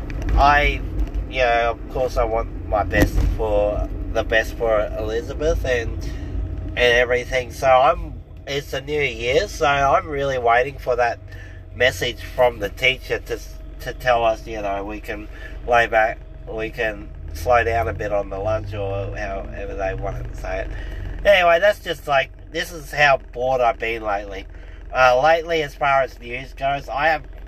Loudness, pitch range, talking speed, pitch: -20 LUFS, 95-130 Hz, 175 wpm, 110 Hz